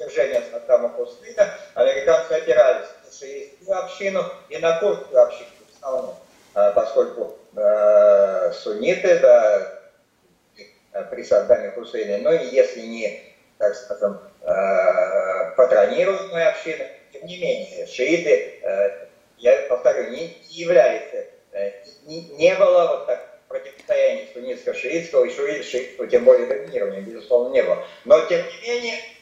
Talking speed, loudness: 125 wpm, -20 LUFS